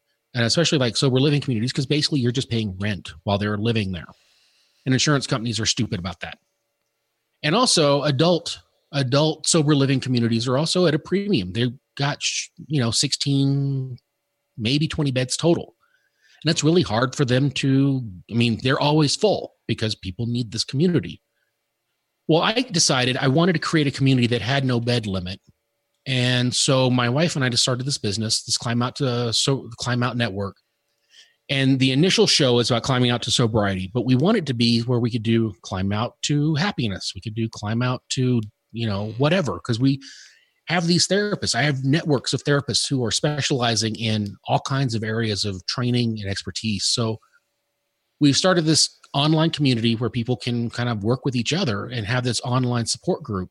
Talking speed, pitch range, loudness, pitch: 190 wpm, 115-145 Hz, -21 LUFS, 125 Hz